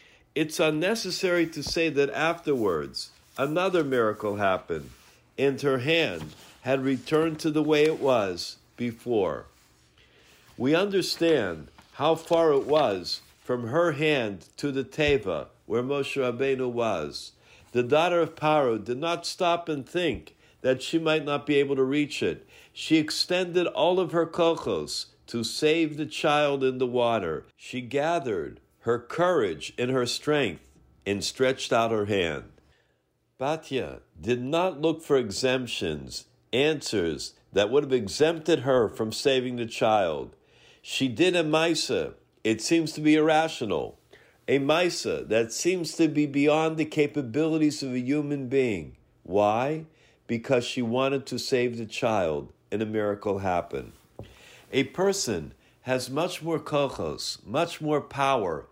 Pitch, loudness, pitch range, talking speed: 145 Hz, -26 LUFS, 125-160 Hz, 140 wpm